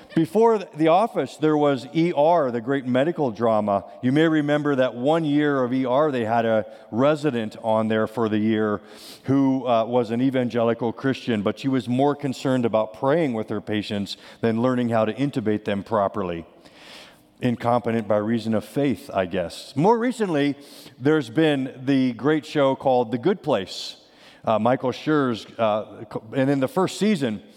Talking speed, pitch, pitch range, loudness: 170 wpm, 130 Hz, 115-145 Hz, -22 LUFS